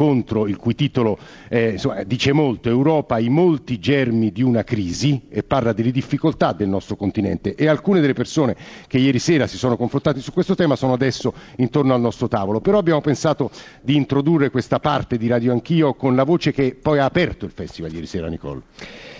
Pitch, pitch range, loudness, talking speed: 130 Hz, 115-145 Hz, -19 LUFS, 195 wpm